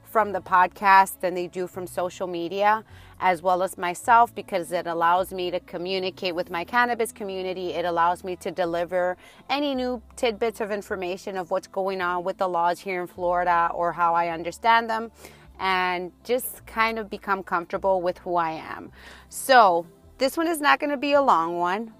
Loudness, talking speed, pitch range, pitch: -24 LUFS, 185 wpm, 175-210 Hz, 185 Hz